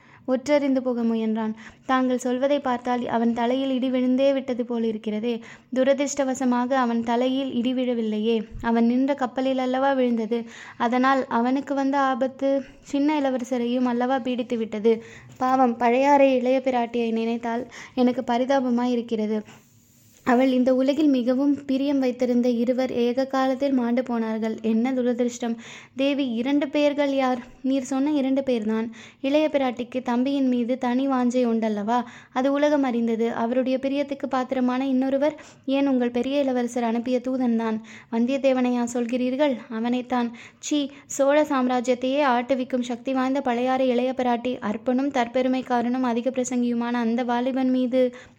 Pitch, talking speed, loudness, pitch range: 255 Hz, 125 wpm, -23 LUFS, 240-265 Hz